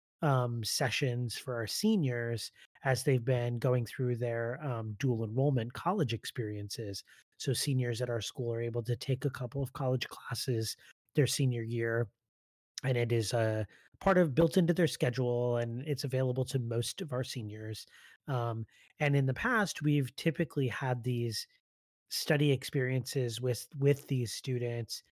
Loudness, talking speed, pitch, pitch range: -33 LUFS, 155 wpm, 125 Hz, 115-140 Hz